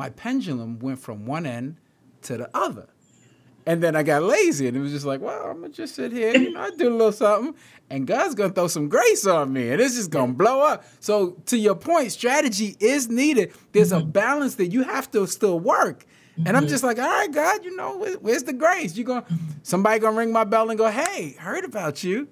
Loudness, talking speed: -22 LUFS, 230 wpm